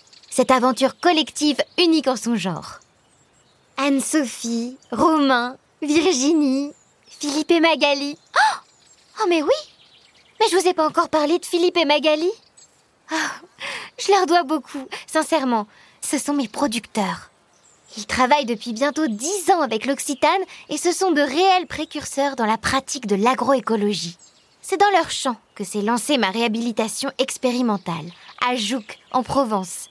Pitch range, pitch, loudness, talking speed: 240-320 Hz, 280 Hz, -20 LUFS, 140 wpm